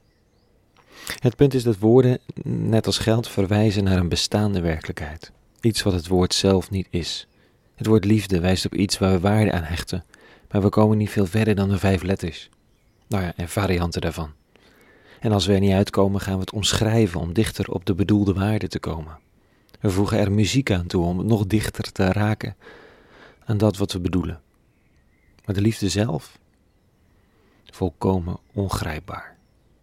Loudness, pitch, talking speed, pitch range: -22 LUFS, 100 Hz, 175 wpm, 90-110 Hz